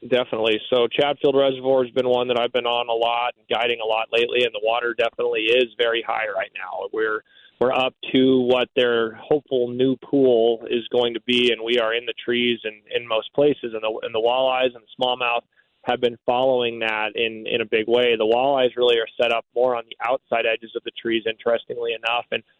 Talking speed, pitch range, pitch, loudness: 220 wpm, 115-130 Hz, 125 Hz, -21 LUFS